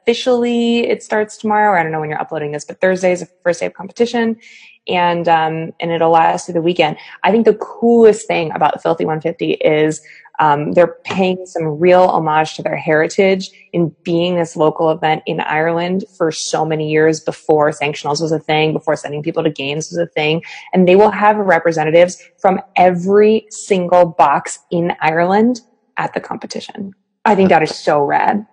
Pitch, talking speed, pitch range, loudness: 175 Hz, 185 wpm, 160-200 Hz, -15 LUFS